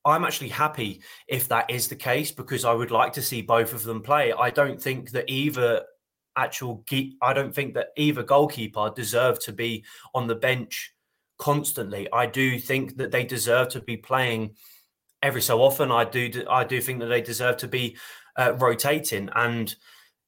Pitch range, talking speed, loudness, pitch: 115-140 Hz, 185 wpm, -25 LUFS, 125 Hz